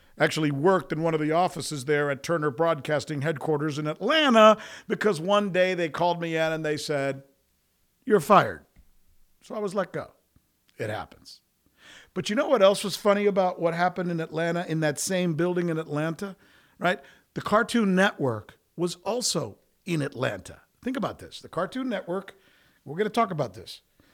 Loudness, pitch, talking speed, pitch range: -25 LUFS, 170 Hz, 175 wpm, 150-200 Hz